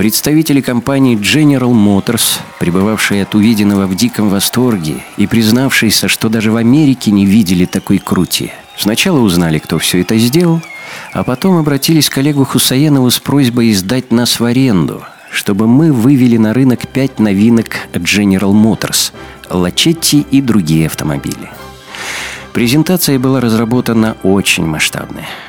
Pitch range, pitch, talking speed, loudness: 100-135 Hz, 115 Hz, 130 wpm, -11 LUFS